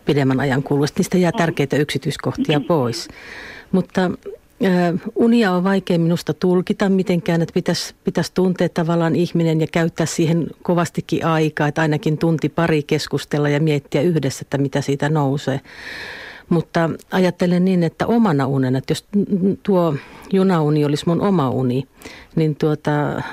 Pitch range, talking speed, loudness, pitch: 150-180 Hz, 140 wpm, -19 LUFS, 165 Hz